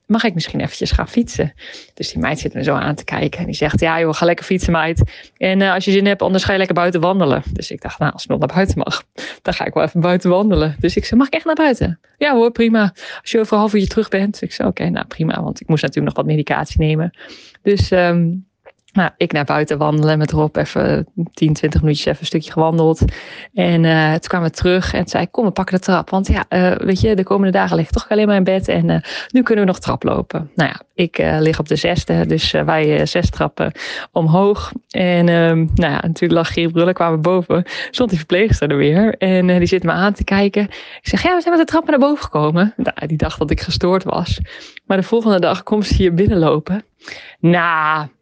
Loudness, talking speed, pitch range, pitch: -16 LUFS, 255 wpm, 160-200 Hz, 180 Hz